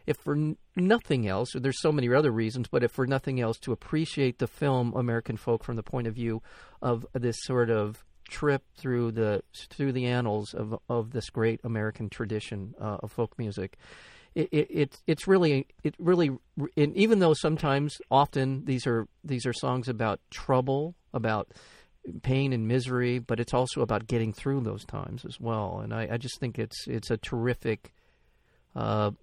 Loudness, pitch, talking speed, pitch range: -29 LUFS, 125 Hz, 185 wpm, 115-140 Hz